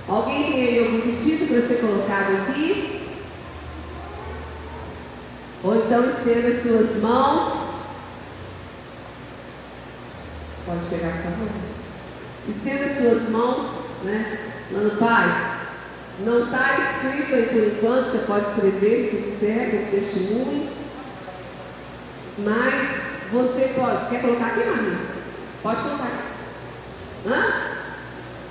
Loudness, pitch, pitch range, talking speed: -22 LUFS, 225 Hz, 190-245 Hz, 105 wpm